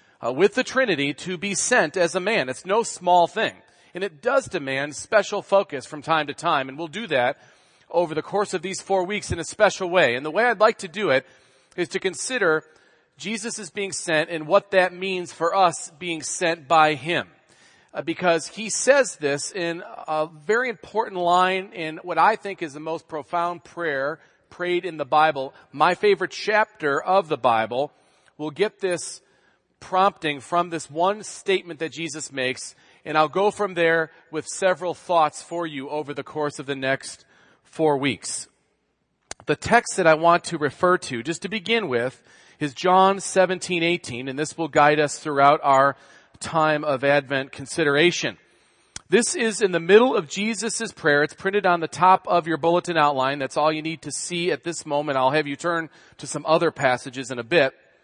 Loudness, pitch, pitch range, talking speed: -22 LUFS, 170 Hz, 150-190 Hz, 190 wpm